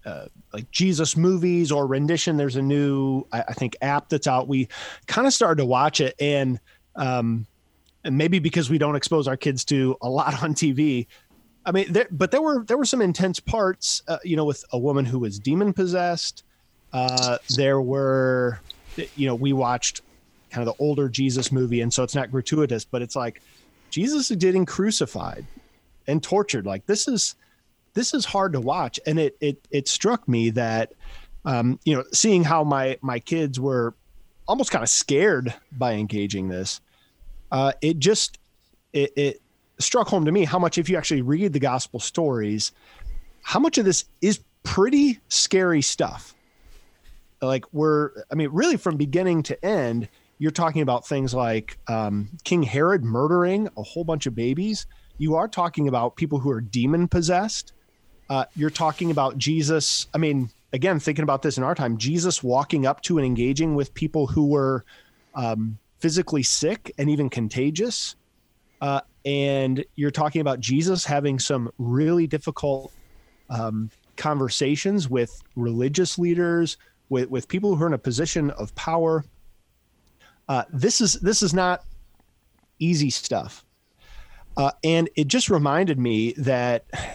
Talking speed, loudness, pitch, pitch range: 170 wpm, -23 LUFS, 145 Hz, 125-170 Hz